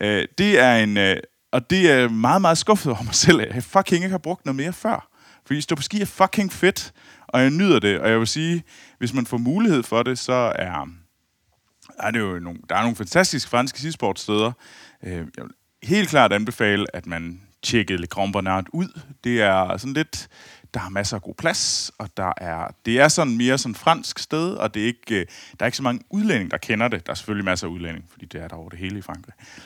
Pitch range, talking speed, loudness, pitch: 100-155 Hz, 230 wpm, -21 LUFS, 120 Hz